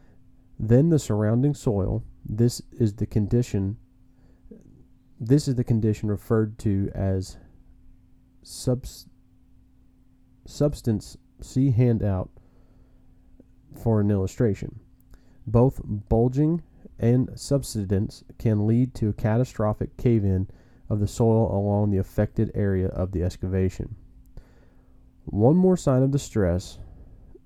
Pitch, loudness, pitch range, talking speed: 115 Hz, -24 LUFS, 100-125 Hz, 105 wpm